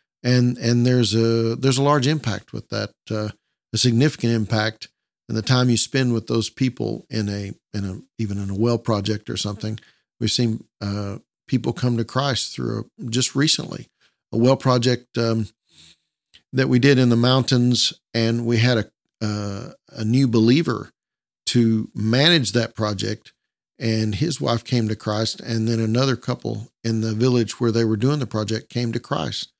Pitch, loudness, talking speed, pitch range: 115 Hz, -21 LUFS, 180 wpm, 110-125 Hz